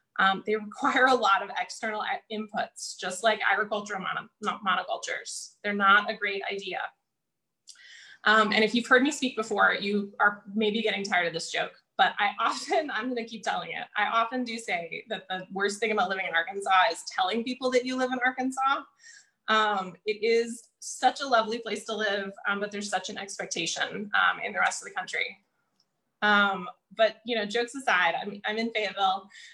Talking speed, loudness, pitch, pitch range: 195 wpm, -27 LUFS, 215 Hz, 200-235 Hz